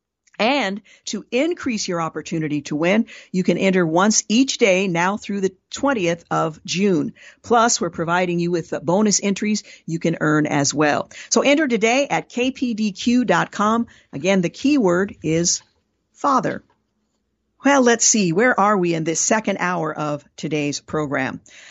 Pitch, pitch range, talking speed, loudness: 190 Hz, 170-230 Hz, 150 wpm, -19 LUFS